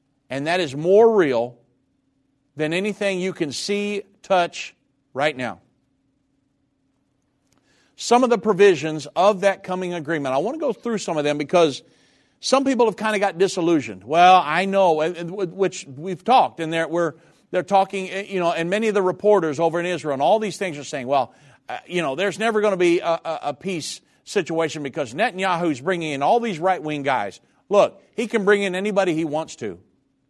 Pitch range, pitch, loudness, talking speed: 150-195 Hz, 175 Hz, -21 LUFS, 185 wpm